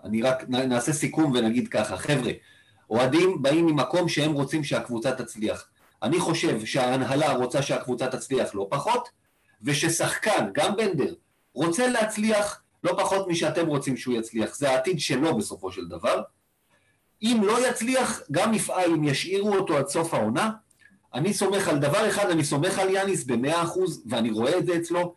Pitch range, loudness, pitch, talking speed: 130-190 Hz, -25 LUFS, 160 Hz, 155 wpm